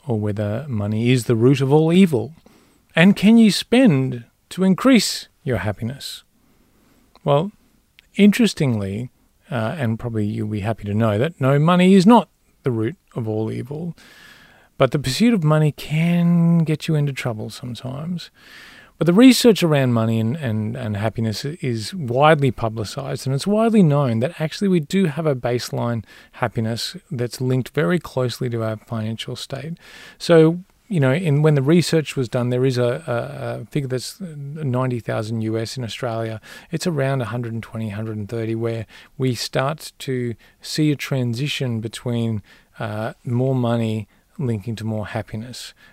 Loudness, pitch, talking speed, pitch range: -20 LUFS, 130 Hz, 155 wpm, 115-160 Hz